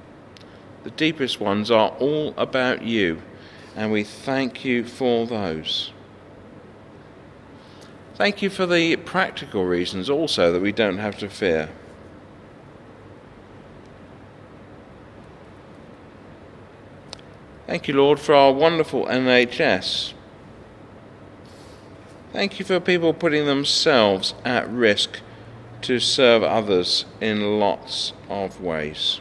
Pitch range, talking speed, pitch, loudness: 100-135 Hz, 100 wpm, 115 Hz, -21 LUFS